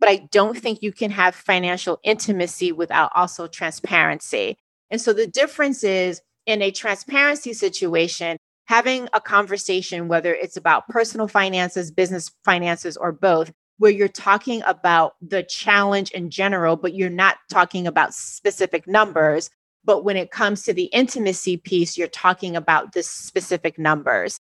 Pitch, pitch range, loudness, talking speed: 190 Hz, 175-210 Hz, -20 LUFS, 150 wpm